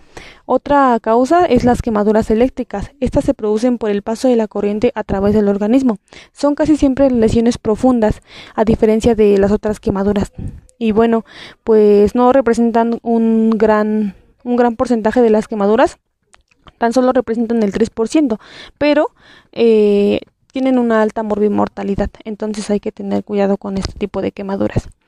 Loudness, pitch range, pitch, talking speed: -15 LUFS, 210-245 Hz, 225 Hz, 155 wpm